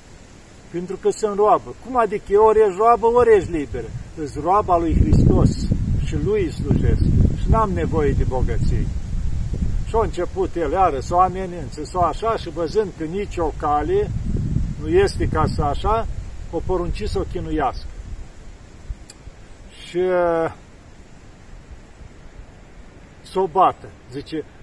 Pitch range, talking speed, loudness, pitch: 145-215 Hz, 135 wpm, -20 LUFS, 180 Hz